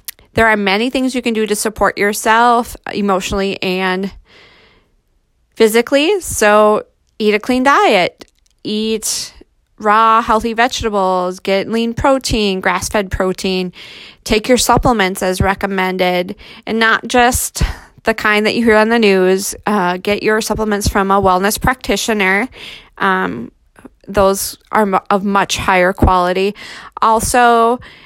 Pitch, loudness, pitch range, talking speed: 210 Hz, -14 LUFS, 195-225 Hz, 130 wpm